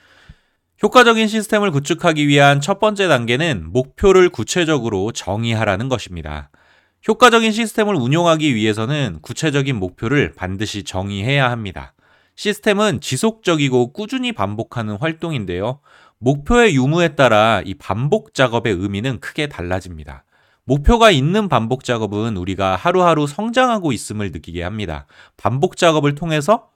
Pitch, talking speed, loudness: 135 Hz, 345 characters per minute, -17 LUFS